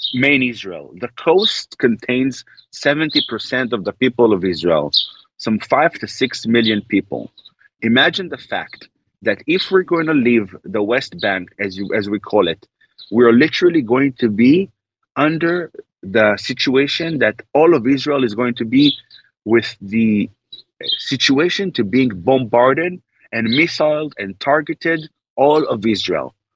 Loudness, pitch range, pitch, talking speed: -16 LUFS, 115-155 Hz, 125 Hz, 145 wpm